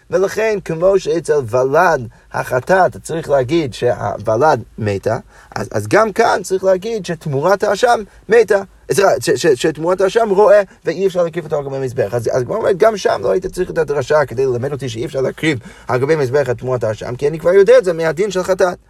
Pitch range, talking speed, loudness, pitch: 140-200 Hz, 185 wpm, -15 LUFS, 170 Hz